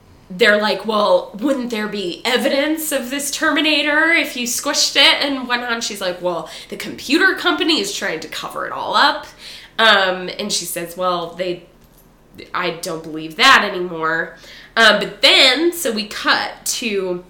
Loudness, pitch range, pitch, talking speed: -16 LUFS, 180-280 Hz, 220 Hz, 165 wpm